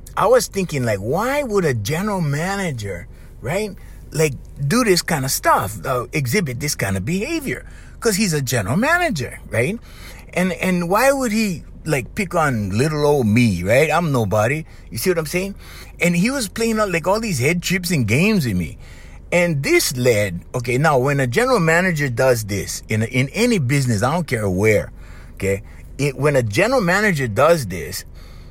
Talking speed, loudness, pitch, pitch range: 185 wpm, -19 LUFS, 150 Hz, 115-185 Hz